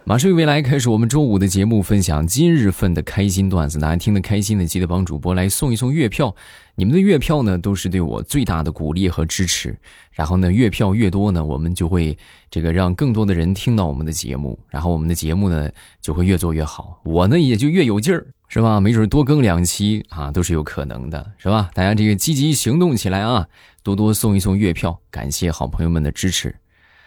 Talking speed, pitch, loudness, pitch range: 335 characters per minute, 95 Hz, -18 LUFS, 85-110 Hz